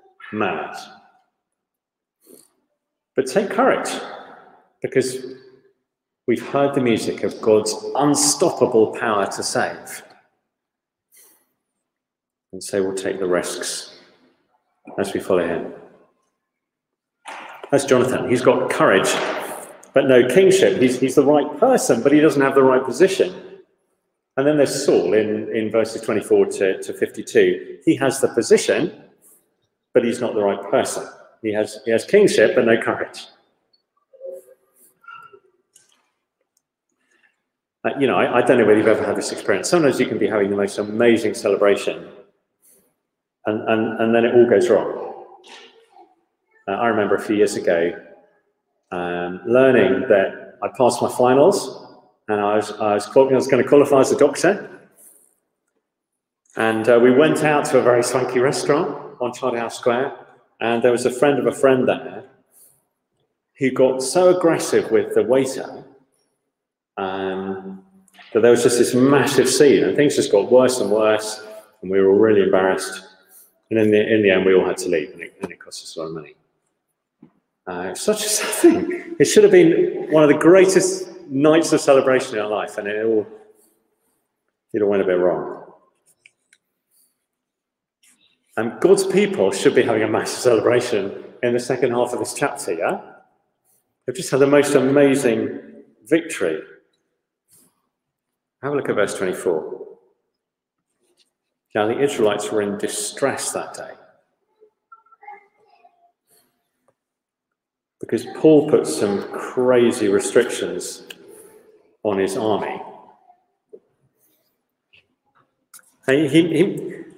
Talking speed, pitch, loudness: 145 wpm, 145 Hz, -18 LUFS